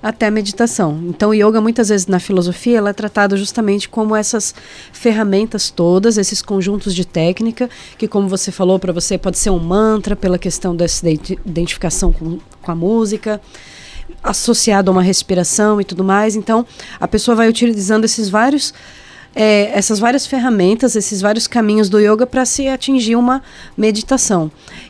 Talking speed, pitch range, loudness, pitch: 165 wpm, 190-225 Hz, -14 LUFS, 210 Hz